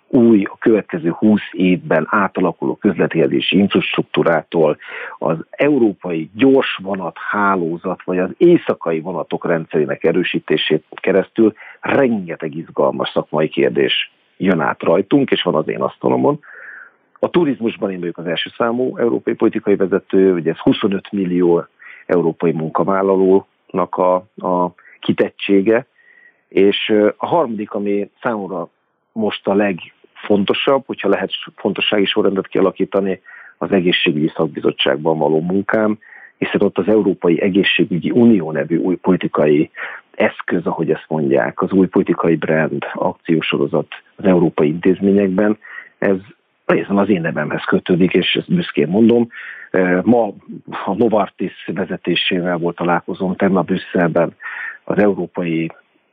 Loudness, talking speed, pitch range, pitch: -17 LUFS, 120 wpm, 90-105 Hz, 95 Hz